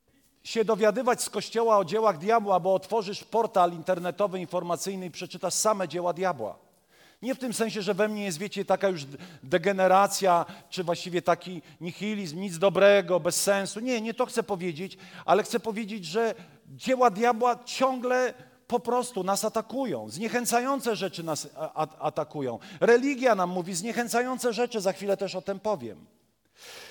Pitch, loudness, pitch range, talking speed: 200 Hz, -27 LUFS, 180-230 Hz, 150 wpm